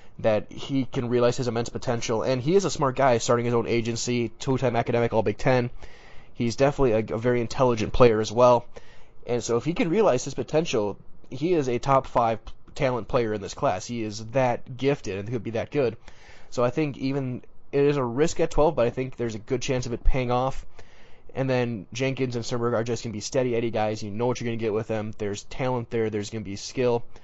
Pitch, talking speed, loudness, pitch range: 120 Hz, 240 wpm, -25 LUFS, 115-130 Hz